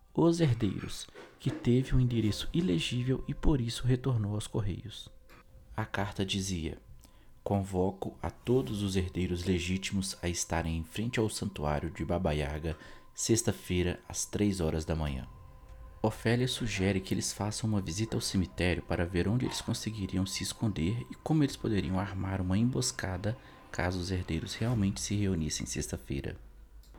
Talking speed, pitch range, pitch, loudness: 150 wpm, 85-110 Hz, 95 Hz, -32 LUFS